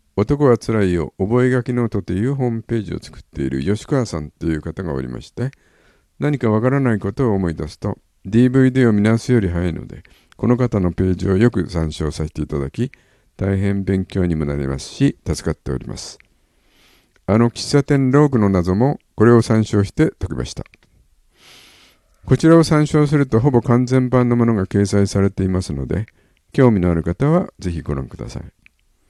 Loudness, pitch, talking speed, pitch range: -18 LUFS, 100 Hz, 355 characters per minute, 85-125 Hz